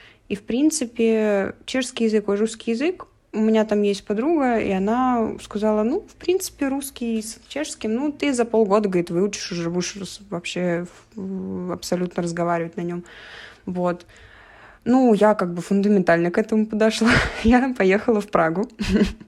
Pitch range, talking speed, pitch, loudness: 190-235 Hz, 150 wpm, 215 Hz, -22 LUFS